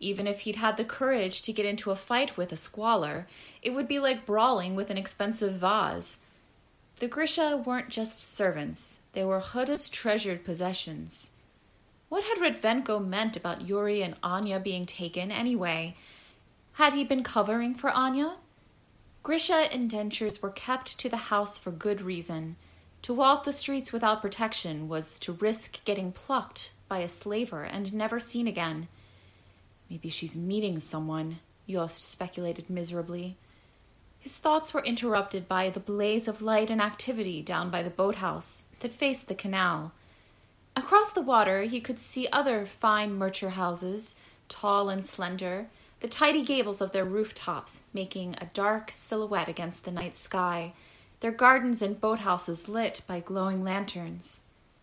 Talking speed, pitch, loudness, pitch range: 150 wpm, 200 Hz, -29 LUFS, 180-235 Hz